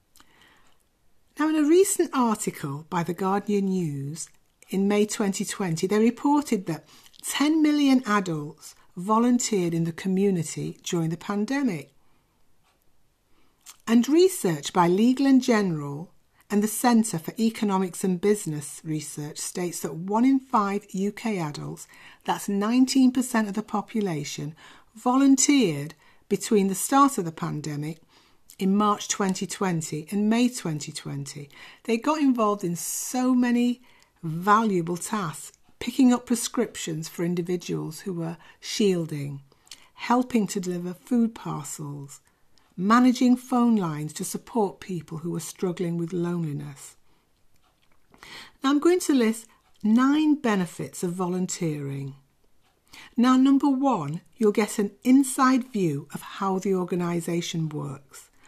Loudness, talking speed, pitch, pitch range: -25 LUFS, 120 wpm, 200 Hz, 170-235 Hz